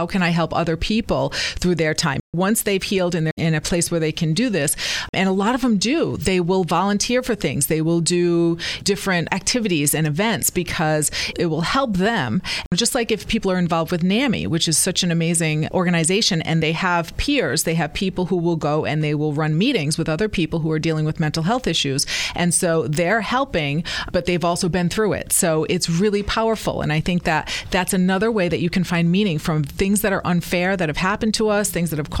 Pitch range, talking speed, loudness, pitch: 160-195 Hz, 230 wpm, -20 LUFS, 175 Hz